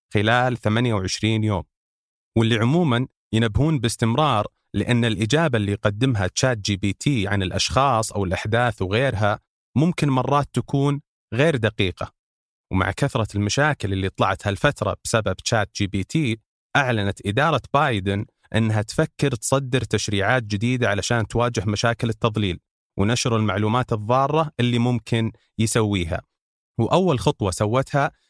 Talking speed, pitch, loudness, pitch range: 120 wpm, 115 Hz, -22 LUFS, 105-130 Hz